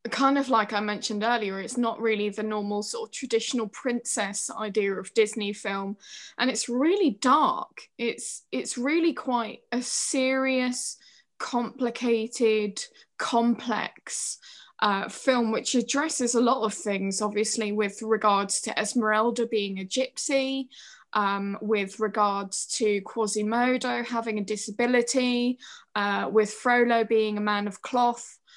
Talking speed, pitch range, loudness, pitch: 130 wpm, 210-245 Hz, -26 LUFS, 225 Hz